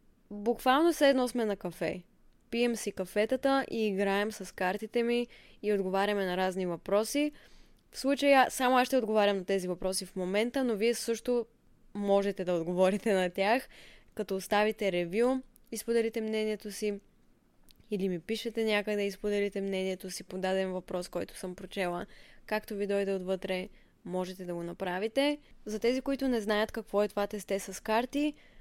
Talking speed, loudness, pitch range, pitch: 160 wpm, -31 LUFS, 190-235 Hz, 210 Hz